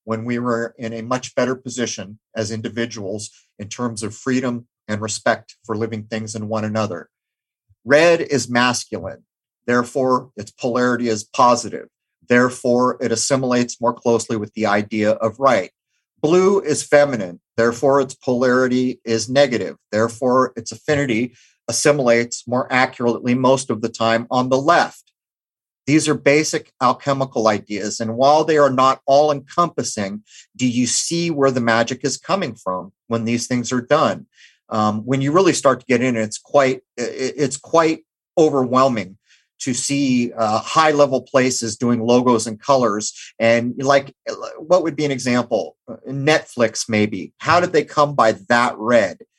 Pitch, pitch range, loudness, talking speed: 125 Hz, 115-135 Hz, -18 LUFS, 155 wpm